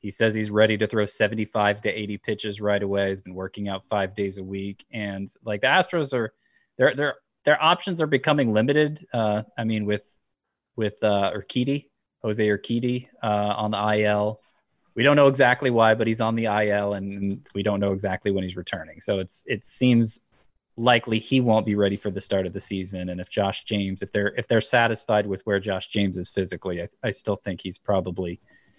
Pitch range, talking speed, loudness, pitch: 100-115 Hz, 205 wpm, -24 LUFS, 105 Hz